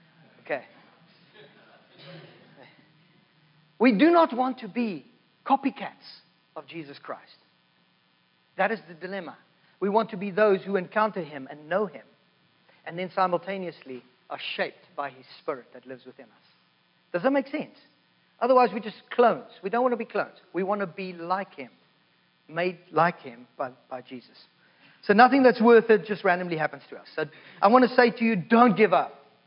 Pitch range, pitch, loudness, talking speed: 140-225 Hz, 185 Hz, -25 LUFS, 170 wpm